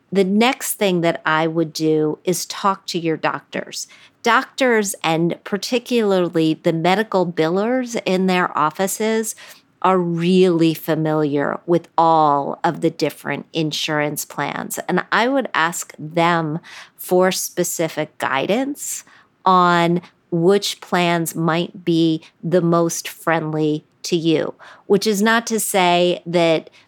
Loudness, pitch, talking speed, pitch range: -19 LUFS, 170 Hz, 125 wpm, 160-195 Hz